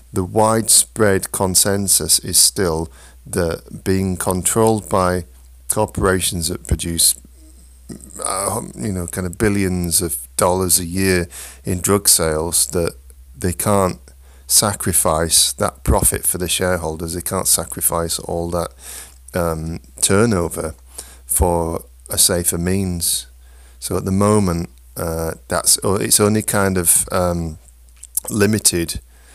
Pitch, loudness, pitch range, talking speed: 85 Hz, -17 LUFS, 65-95 Hz, 115 wpm